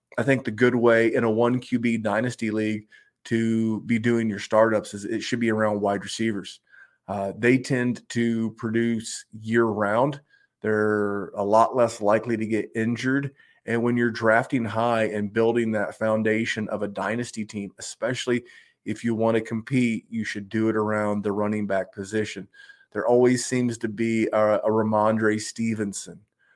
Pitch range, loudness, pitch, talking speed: 105-120 Hz, -24 LUFS, 110 Hz, 170 wpm